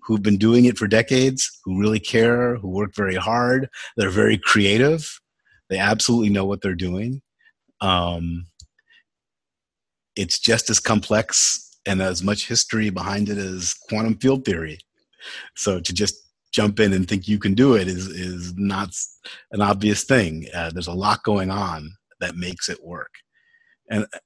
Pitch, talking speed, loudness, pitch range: 100 Hz, 160 wpm, -20 LUFS, 95-115 Hz